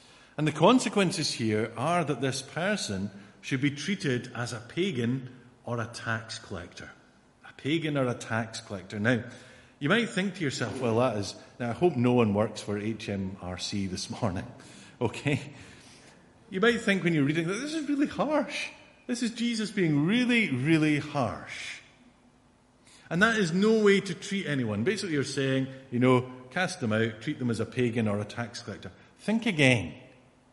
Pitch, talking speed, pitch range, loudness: 130 Hz, 175 wpm, 115-175 Hz, -28 LUFS